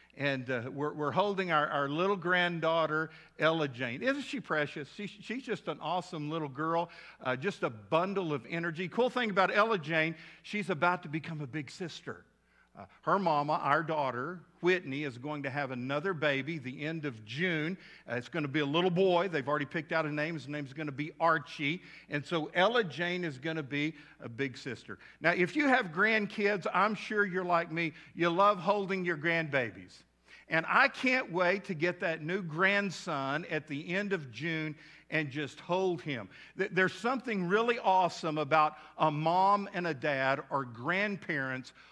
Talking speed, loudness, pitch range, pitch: 190 wpm, -32 LUFS, 150-185 Hz, 165 Hz